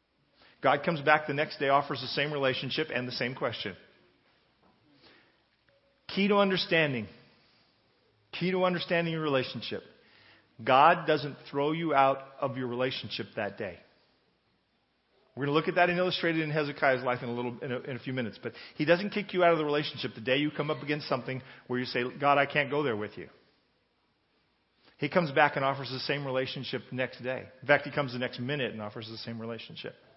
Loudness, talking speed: -29 LUFS, 205 wpm